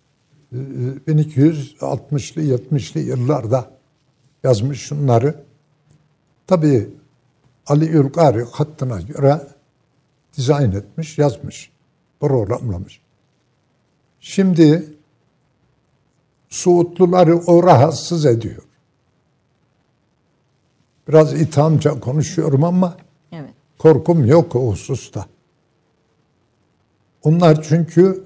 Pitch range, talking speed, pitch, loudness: 135-160 Hz, 60 wpm, 145 Hz, -16 LUFS